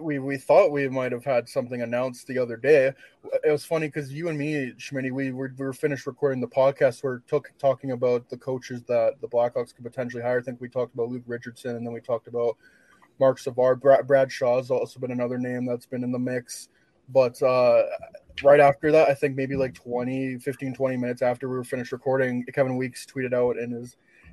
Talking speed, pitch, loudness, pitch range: 220 wpm, 130 Hz, -25 LUFS, 125-140 Hz